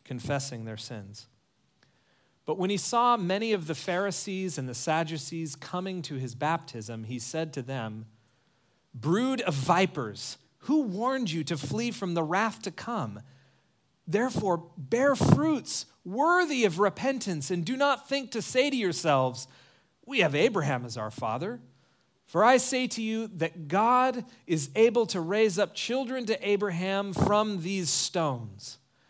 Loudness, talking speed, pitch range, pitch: -28 LUFS, 150 wpm, 135-220 Hz, 175 Hz